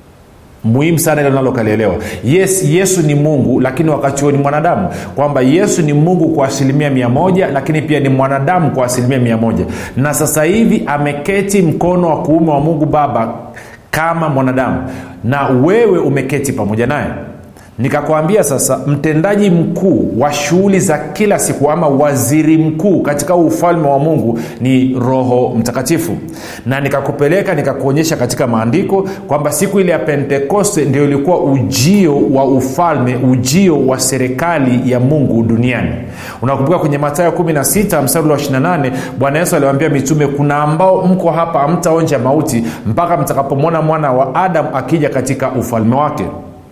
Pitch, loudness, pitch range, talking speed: 145 Hz, -12 LUFS, 130-165 Hz, 135 wpm